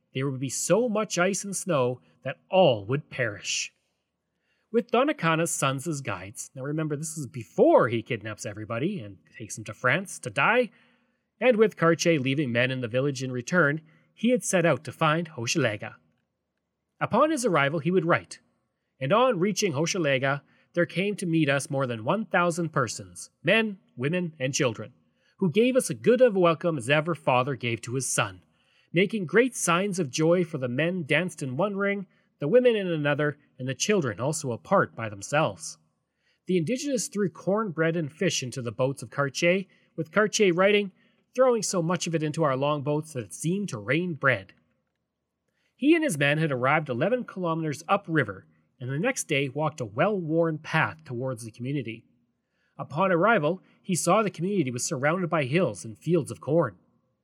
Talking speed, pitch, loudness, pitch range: 185 wpm, 160 Hz, -26 LUFS, 130-190 Hz